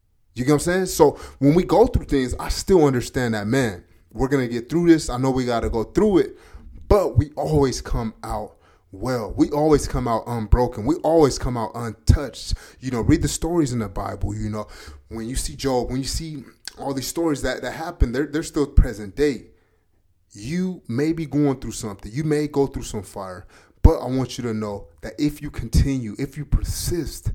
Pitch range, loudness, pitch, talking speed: 110-145 Hz, -22 LUFS, 125 Hz, 215 wpm